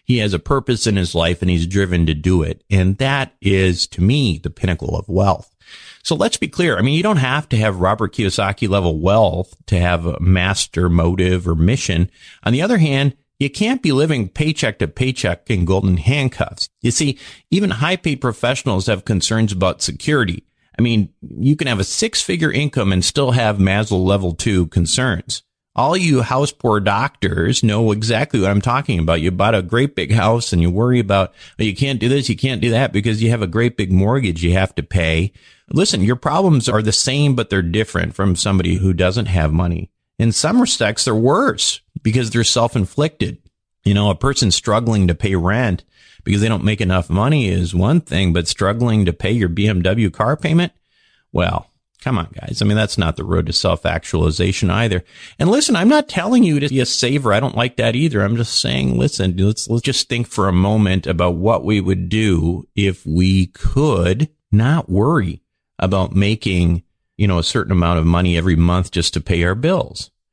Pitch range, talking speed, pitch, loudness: 90-125 Hz, 205 wpm, 105 Hz, -17 LUFS